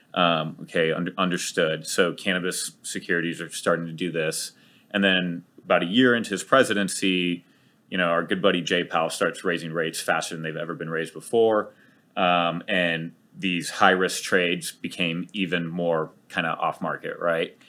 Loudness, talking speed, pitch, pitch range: -24 LUFS, 175 wpm, 85 Hz, 85-95 Hz